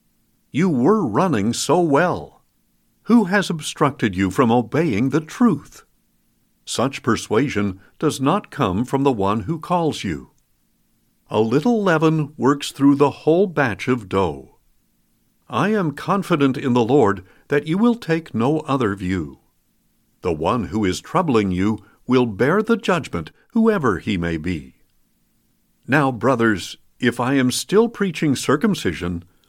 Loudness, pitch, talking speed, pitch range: -20 LUFS, 140 Hz, 140 wpm, 105-160 Hz